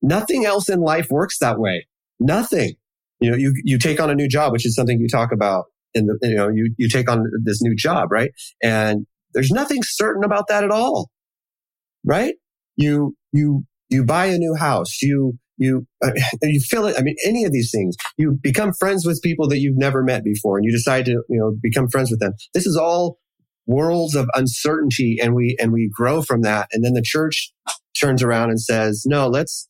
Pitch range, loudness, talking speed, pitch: 115-150 Hz, -19 LUFS, 215 wpm, 130 Hz